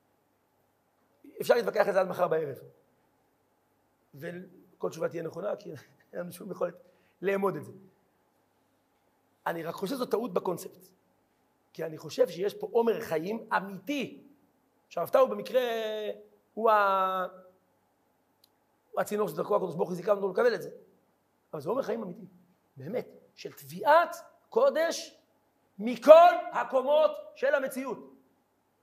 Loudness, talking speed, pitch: -28 LUFS, 125 wpm, 220 Hz